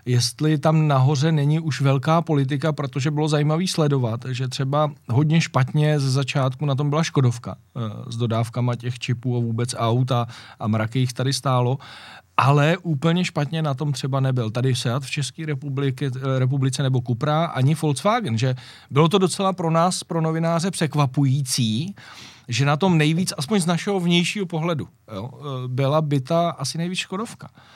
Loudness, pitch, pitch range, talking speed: -22 LUFS, 145 Hz, 130-160 Hz, 160 wpm